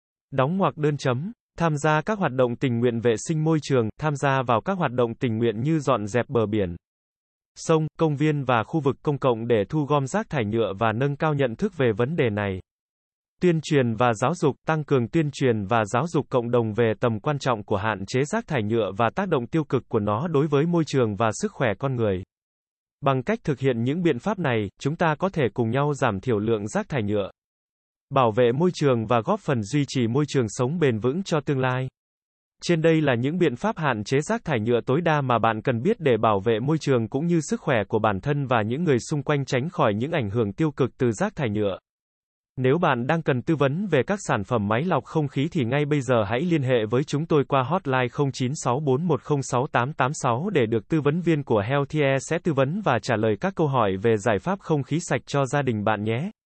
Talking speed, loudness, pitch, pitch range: 240 wpm, -24 LUFS, 135 Hz, 120-155 Hz